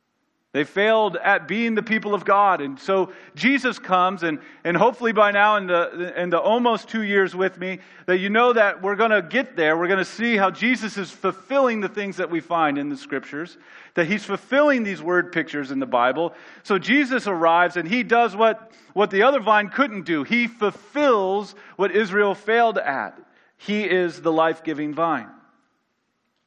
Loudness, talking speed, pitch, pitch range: -21 LUFS, 195 wpm, 200 Hz, 175-225 Hz